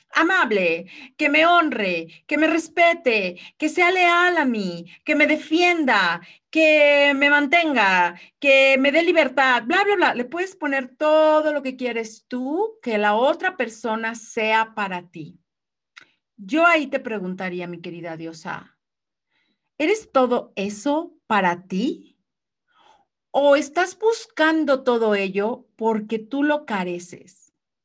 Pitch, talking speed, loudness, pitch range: 270 Hz, 130 wpm, -20 LUFS, 205-315 Hz